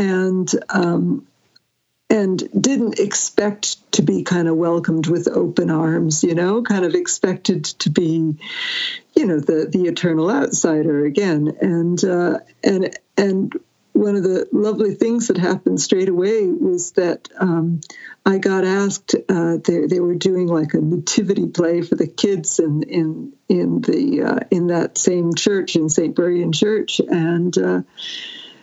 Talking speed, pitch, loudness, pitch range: 155 wpm, 185 Hz, -18 LUFS, 170-210 Hz